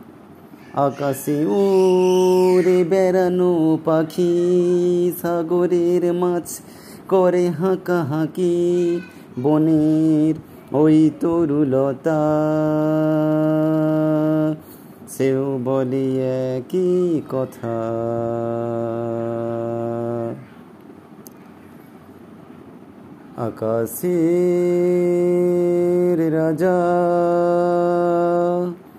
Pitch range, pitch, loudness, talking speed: 140-175 Hz, 160 Hz, -19 LUFS, 35 wpm